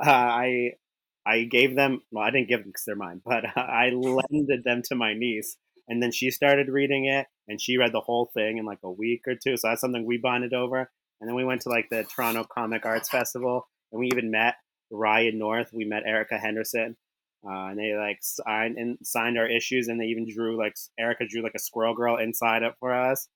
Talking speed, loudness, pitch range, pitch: 230 wpm, -26 LUFS, 110-125 Hz, 120 Hz